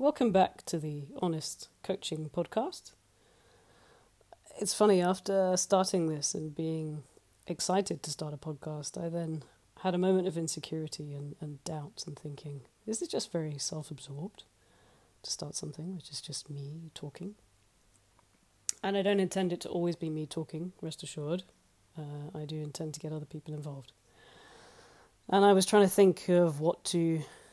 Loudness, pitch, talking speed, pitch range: -32 LUFS, 160 Hz, 160 wpm, 150-185 Hz